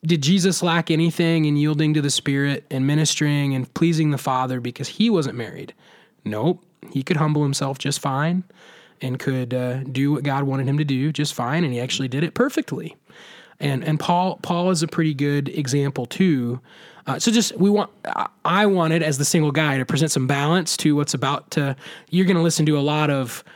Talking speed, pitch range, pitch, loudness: 205 wpm, 135-170 Hz, 150 Hz, -21 LUFS